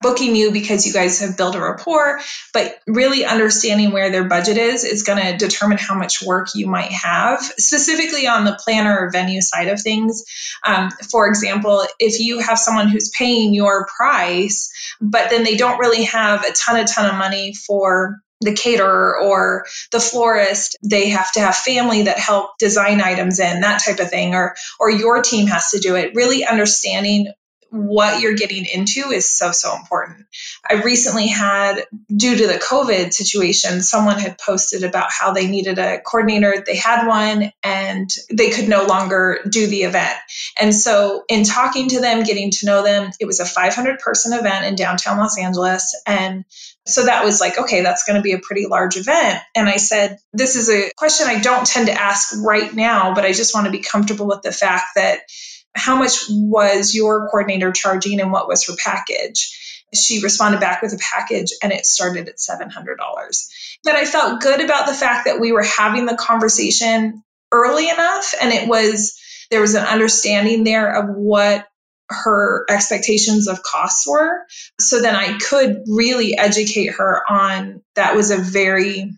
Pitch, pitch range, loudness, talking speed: 210 Hz, 200-230 Hz, -15 LUFS, 185 wpm